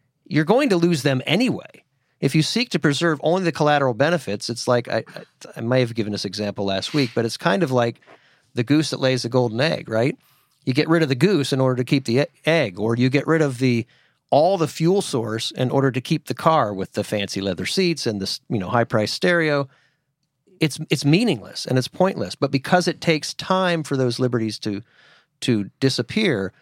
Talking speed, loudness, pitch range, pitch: 215 wpm, -21 LUFS, 120-160 Hz, 135 Hz